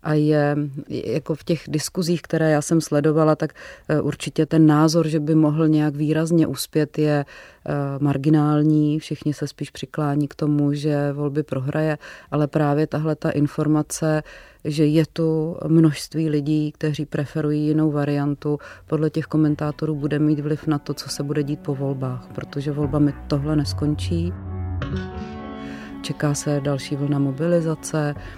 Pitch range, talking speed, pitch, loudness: 145-155 Hz, 145 wpm, 150 Hz, -22 LUFS